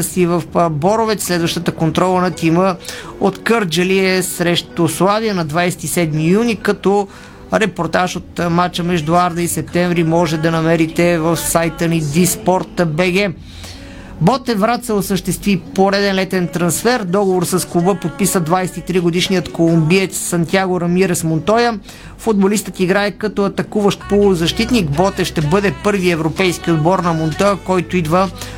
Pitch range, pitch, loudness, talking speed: 170-195 Hz, 180 Hz, -15 LUFS, 125 wpm